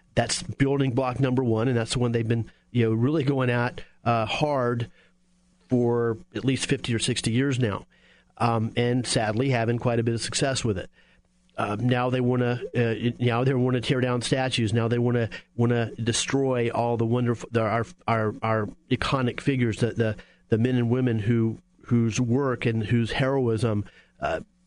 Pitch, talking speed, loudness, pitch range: 120 Hz, 190 wpm, -25 LUFS, 115-130 Hz